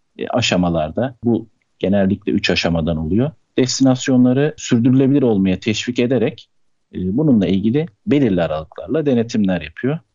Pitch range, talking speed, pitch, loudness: 90-130 Hz, 100 wpm, 115 Hz, -17 LUFS